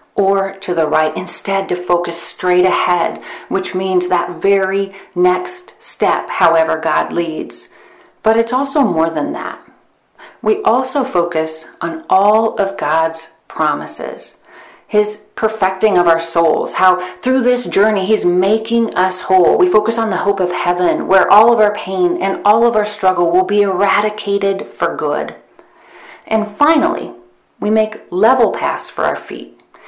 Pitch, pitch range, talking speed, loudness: 195 Hz, 180-220 Hz, 155 wpm, -15 LUFS